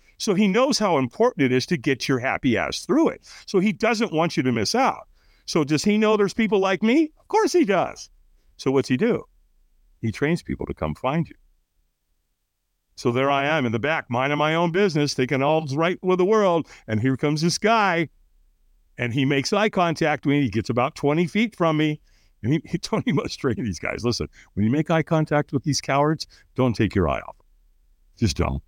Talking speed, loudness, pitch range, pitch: 220 wpm, -22 LUFS, 120-175 Hz, 145 Hz